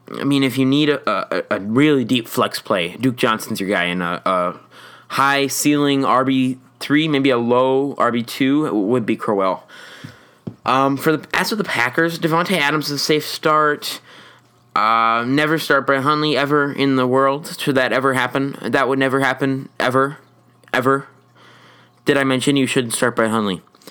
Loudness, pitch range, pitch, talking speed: -18 LUFS, 125-145 Hz, 135 Hz, 180 wpm